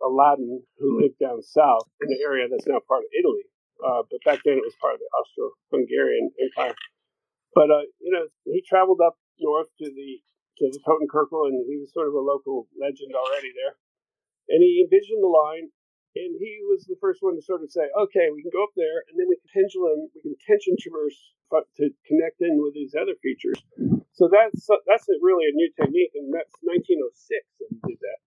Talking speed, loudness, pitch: 210 wpm, -23 LUFS, 370 Hz